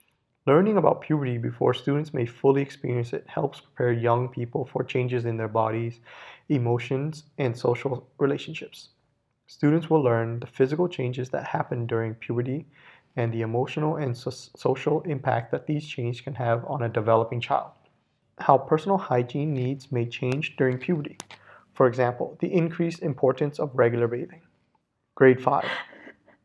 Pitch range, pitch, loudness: 120-145 Hz, 130 Hz, -26 LUFS